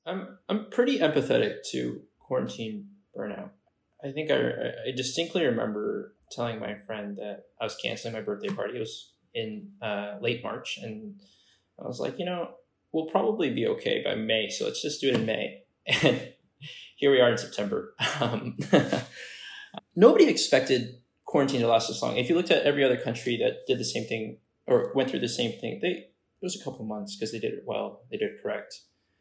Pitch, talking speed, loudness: 145 Hz, 195 wpm, -28 LUFS